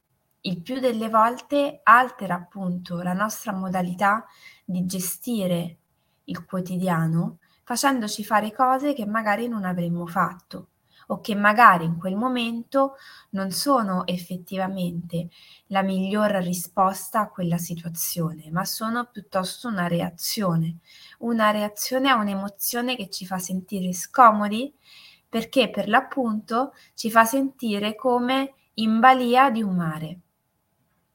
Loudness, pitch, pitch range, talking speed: -23 LUFS, 205 Hz, 180-235 Hz, 120 wpm